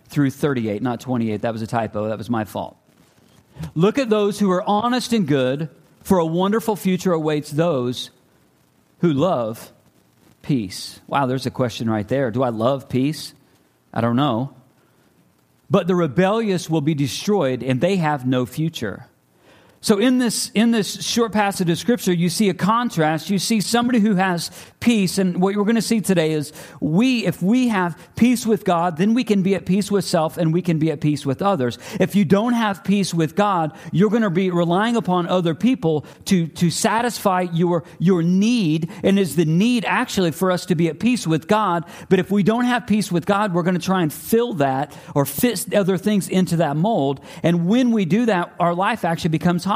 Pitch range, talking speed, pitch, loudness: 150-205 Hz, 200 wpm, 180 Hz, -20 LUFS